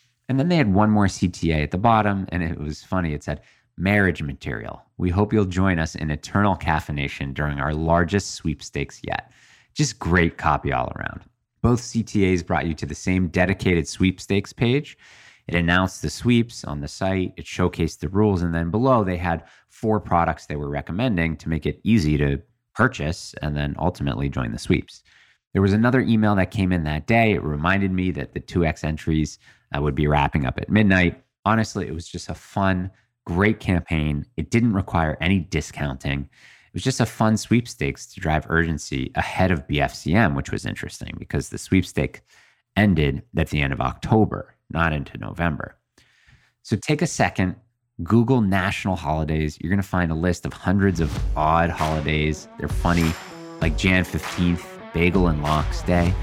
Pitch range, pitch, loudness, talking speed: 80-105 Hz, 90 Hz, -22 LUFS, 180 wpm